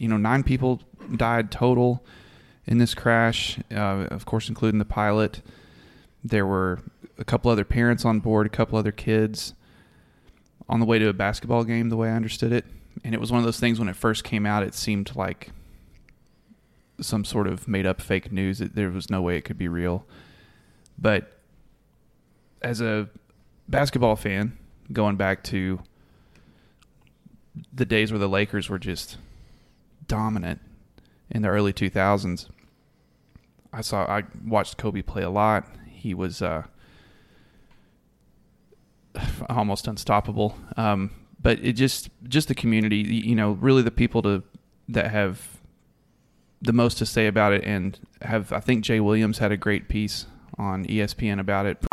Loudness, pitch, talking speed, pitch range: -24 LUFS, 105 Hz, 160 wpm, 100-115 Hz